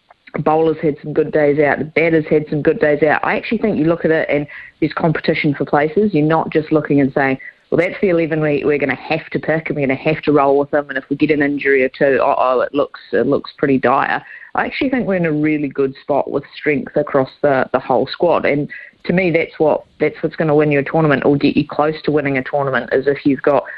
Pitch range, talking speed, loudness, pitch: 145-160 Hz, 275 wpm, -16 LUFS, 150 Hz